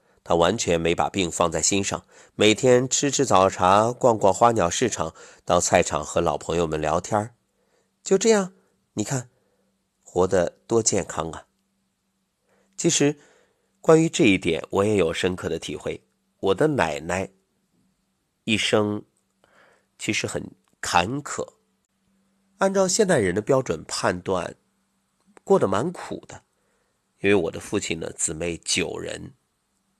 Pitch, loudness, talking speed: 115 Hz, -22 LUFS, 190 characters per minute